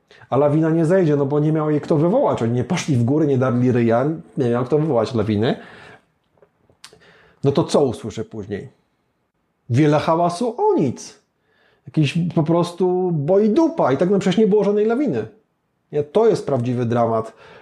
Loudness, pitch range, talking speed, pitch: -19 LUFS, 125-175 Hz, 175 wpm, 150 Hz